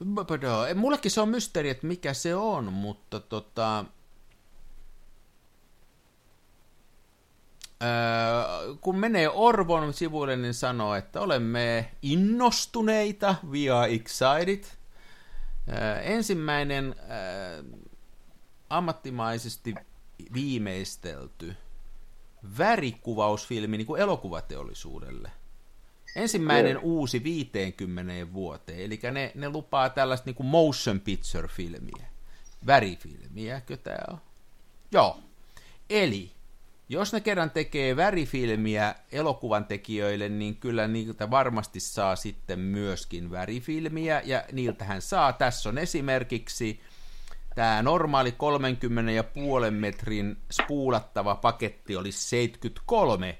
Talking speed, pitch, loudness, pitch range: 85 wpm, 120 Hz, -28 LUFS, 105-150 Hz